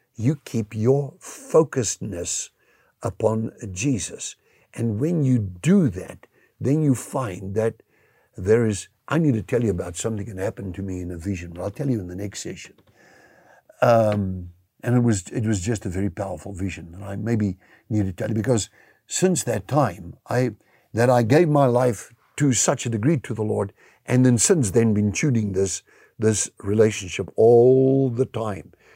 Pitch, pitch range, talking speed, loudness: 110 Hz, 100-130 Hz, 180 wpm, -22 LUFS